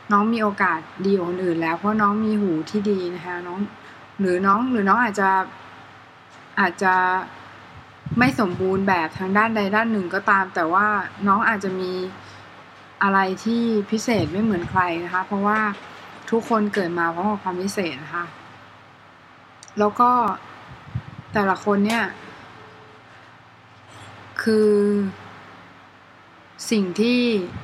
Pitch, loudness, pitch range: 195 Hz, -21 LUFS, 180-210 Hz